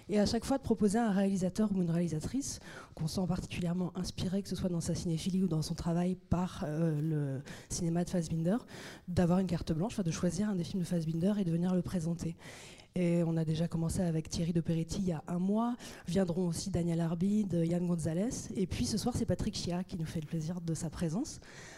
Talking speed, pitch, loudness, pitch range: 230 wpm, 175 Hz, -34 LUFS, 165-190 Hz